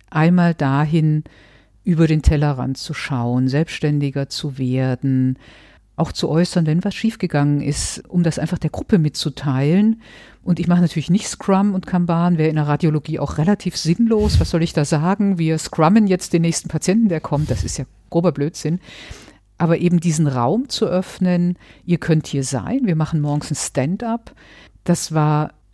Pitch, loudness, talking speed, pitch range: 160 Hz, -19 LUFS, 170 wpm, 145-180 Hz